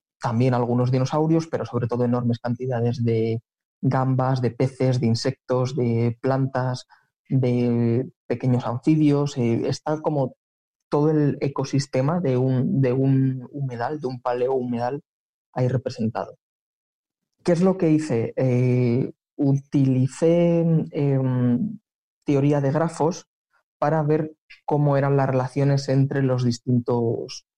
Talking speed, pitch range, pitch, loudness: 120 wpm, 125-145 Hz, 130 Hz, -23 LUFS